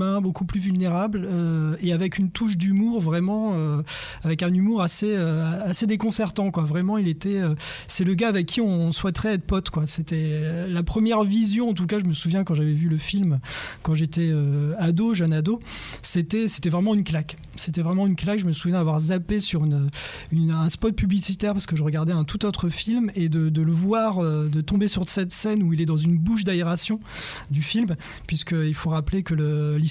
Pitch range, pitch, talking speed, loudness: 160-200 Hz, 175 Hz, 220 wpm, -23 LUFS